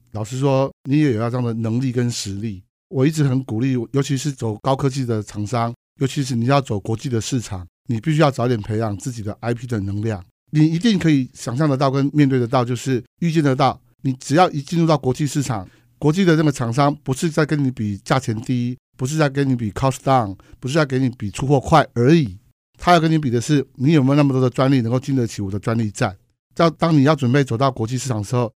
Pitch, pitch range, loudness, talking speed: 130 Hz, 115-145 Hz, -19 LUFS, 360 characters per minute